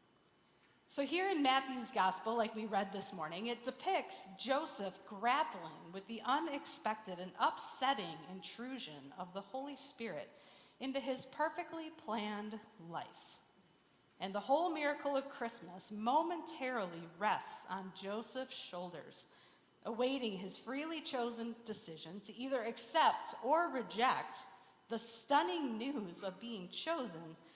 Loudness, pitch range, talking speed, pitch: -40 LUFS, 195-275 Hz, 120 wpm, 230 Hz